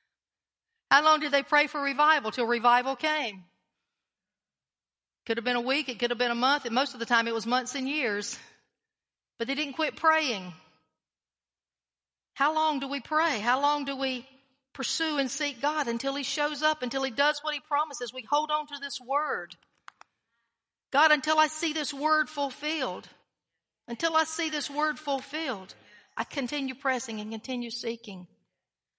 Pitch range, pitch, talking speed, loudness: 240-300 Hz, 275 Hz, 175 wpm, -28 LUFS